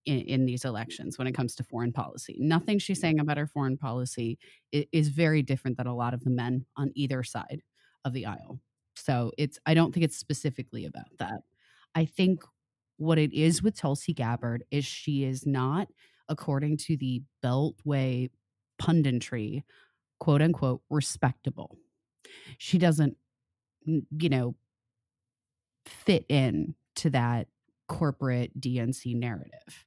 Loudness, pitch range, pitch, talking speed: -29 LUFS, 125-155 Hz, 135 Hz, 145 wpm